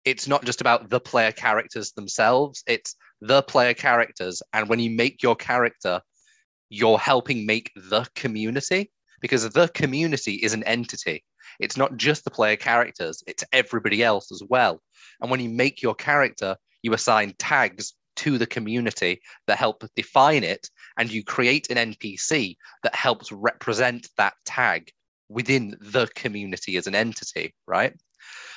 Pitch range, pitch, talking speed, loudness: 110-135 Hz, 120 Hz, 155 wpm, -23 LUFS